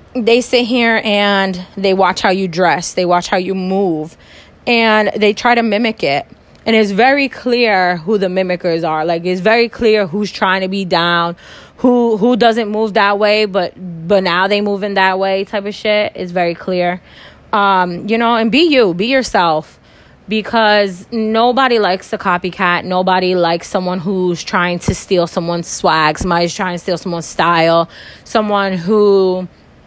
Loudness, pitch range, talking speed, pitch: -14 LUFS, 180-220 Hz, 175 wpm, 195 Hz